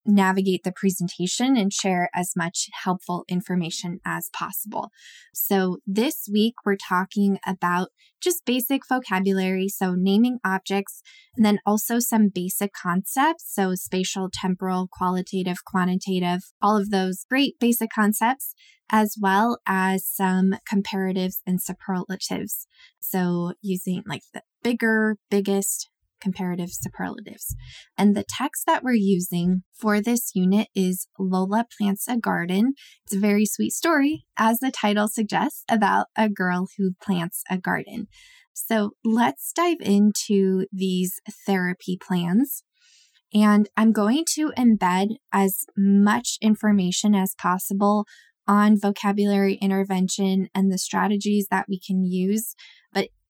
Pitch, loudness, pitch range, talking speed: 200 Hz, -23 LUFS, 185-220 Hz, 125 wpm